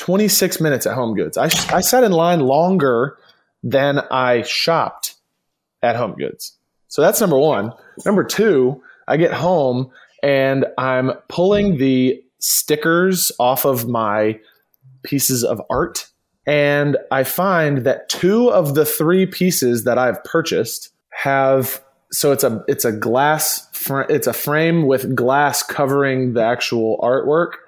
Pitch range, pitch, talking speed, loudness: 130-170 Hz, 140 Hz, 140 wpm, -17 LUFS